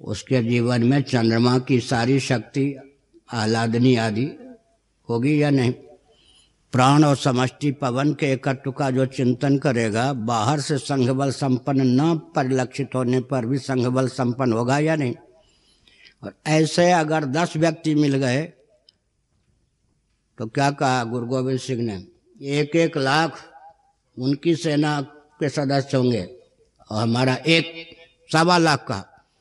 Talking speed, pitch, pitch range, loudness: 130 wpm, 135 Hz, 125-150 Hz, -21 LUFS